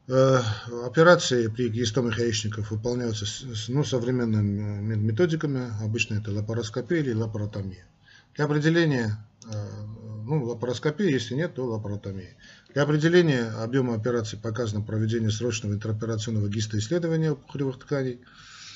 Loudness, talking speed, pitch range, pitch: -26 LUFS, 105 wpm, 110-135 Hz, 120 Hz